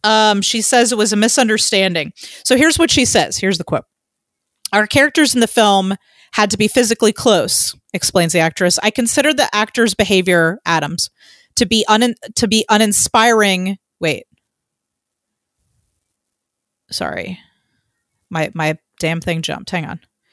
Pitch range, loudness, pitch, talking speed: 185-235 Hz, -14 LUFS, 215 Hz, 145 wpm